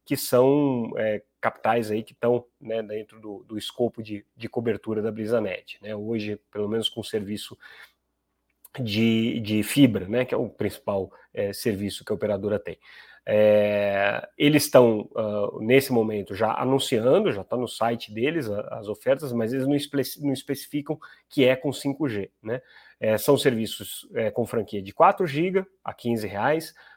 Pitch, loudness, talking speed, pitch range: 115 Hz, -25 LUFS, 170 wpm, 105-135 Hz